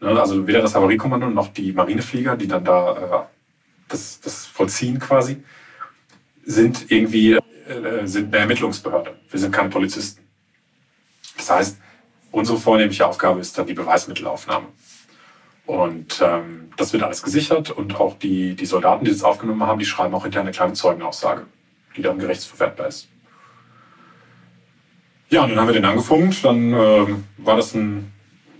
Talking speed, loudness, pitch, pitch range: 150 wpm, -19 LUFS, 110 Hz, 90-120 Hz